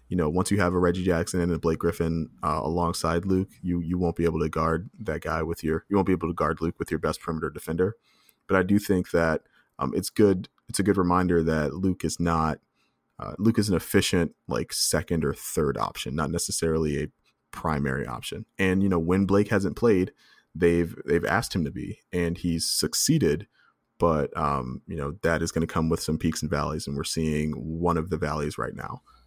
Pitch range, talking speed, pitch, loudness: 80-90 Hz, 220 wpm, 85 Hz, -26 LUFS